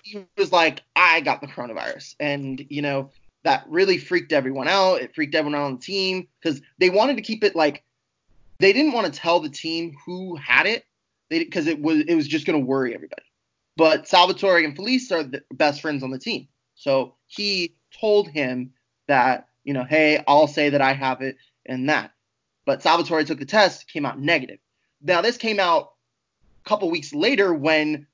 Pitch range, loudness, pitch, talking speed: 145-200 Hz, -21 LUFS, 160 Hz, 200 wpm